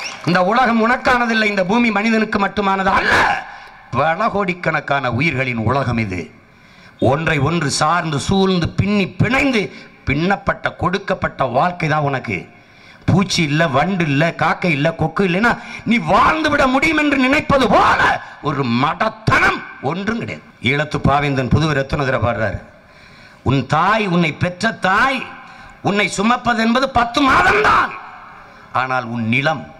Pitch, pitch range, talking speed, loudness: 175 Hz, 140-220 Hz, 125 wpm, -16 LUFS